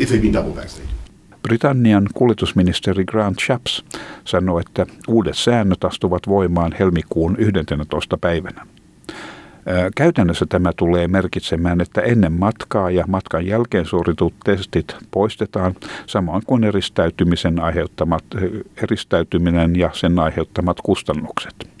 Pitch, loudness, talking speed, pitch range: 90 Hz, -18 LUFS, 95 wpm, 85-105 Hz